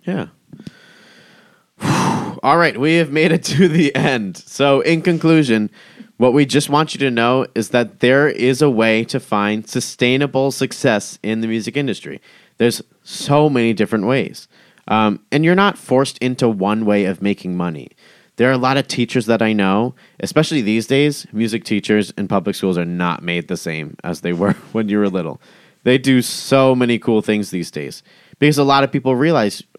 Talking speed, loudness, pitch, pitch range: 190 wpm, -16 LUFS, 125 Hz, 110-145 Hz